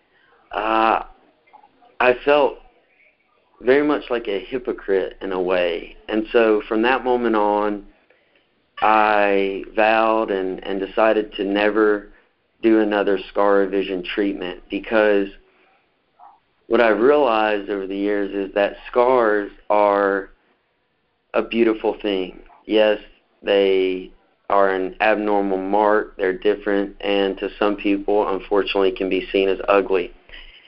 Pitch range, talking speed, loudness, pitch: 100-110 Hz, 120 wpm, -20 LUFS, 100 Hz